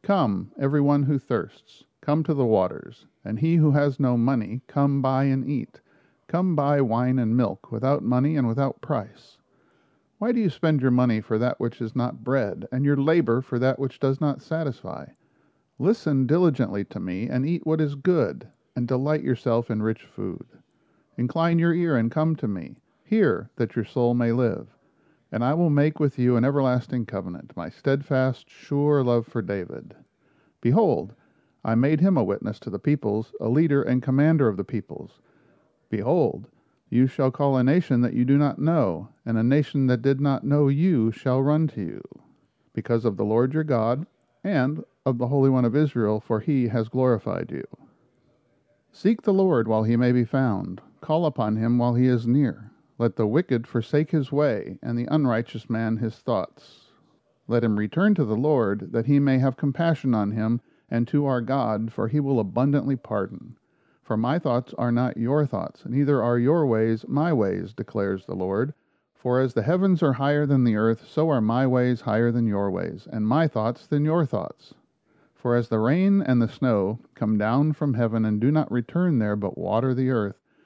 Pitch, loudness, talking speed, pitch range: 130 Hz, -24 LUFS, 190 wpm, 115-145 Hz